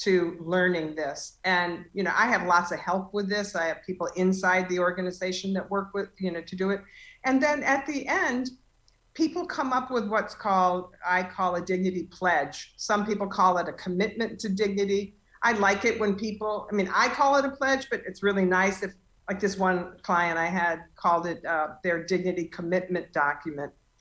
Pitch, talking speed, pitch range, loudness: 185 Hz, 200 wpm, 180-210 Hz, -27 LUFS